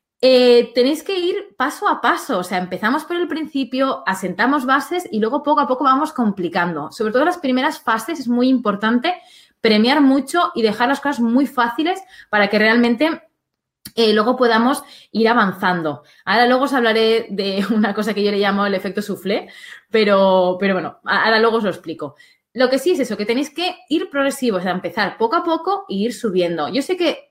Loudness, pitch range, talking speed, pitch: -18 LUFS, 205-285 Hz, 200 wpm, 240 Hz